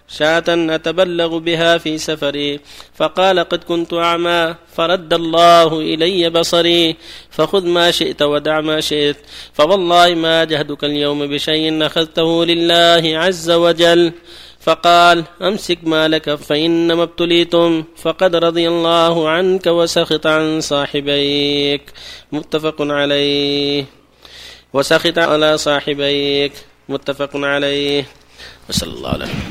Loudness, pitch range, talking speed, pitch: -14 LUFS, 145-170 Hz, 105 wpm, 165 Hz